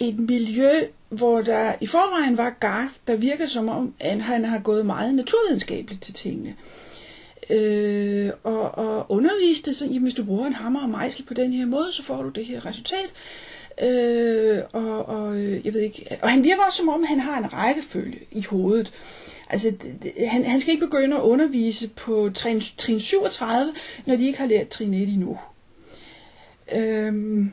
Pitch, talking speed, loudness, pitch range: 235 Hz, 185 wpm, -23 LUFS, 215-270 Hz